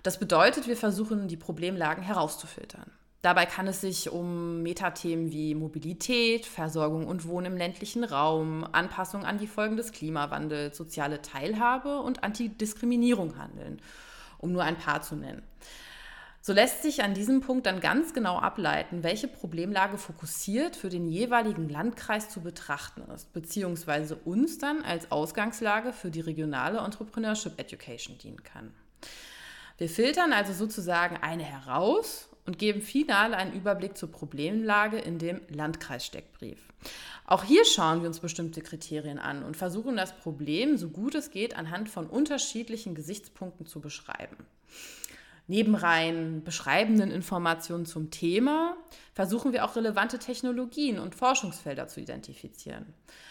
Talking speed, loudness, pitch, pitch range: 140 wpm, -29 LUFS, 185 Hz, 165-225 Hz